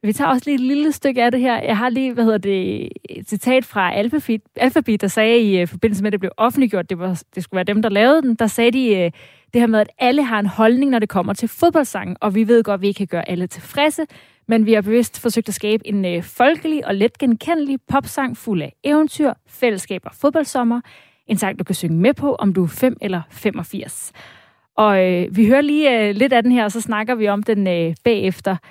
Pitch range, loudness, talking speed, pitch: 200-255 Hz, -18 LUFS, 245 wpm, 225 Hz